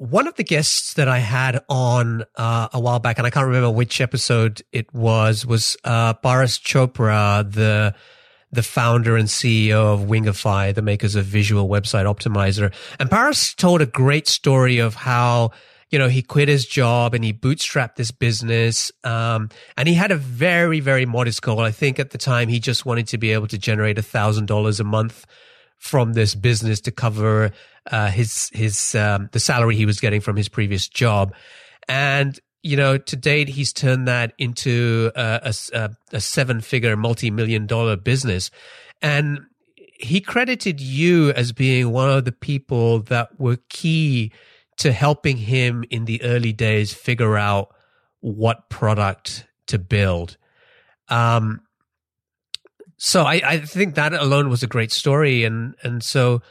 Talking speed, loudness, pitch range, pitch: 170 wpm, -19 LUFS, 110-135 Hz, 120 Hz